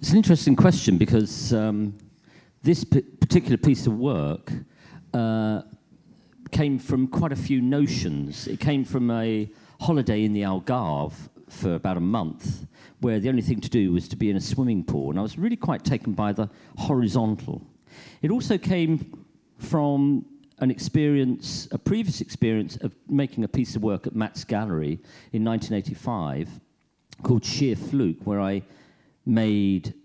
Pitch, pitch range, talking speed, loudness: 120 Hz, 105-140 Hz, 160 wpm, -24 LUFS